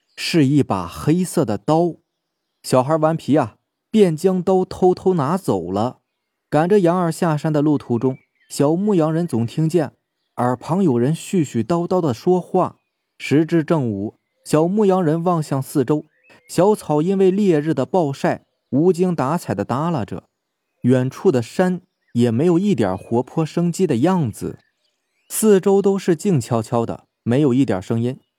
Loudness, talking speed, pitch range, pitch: -19 LUFS, 225 characters per minute, 130-180 Hz, 160 Hz